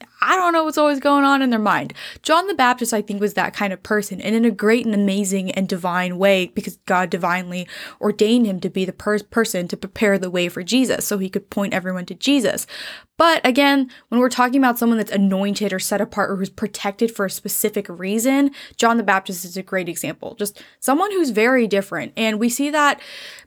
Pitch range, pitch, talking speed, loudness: 195-245 Hz, 210 Hz, 220 wpm, -19 LUFS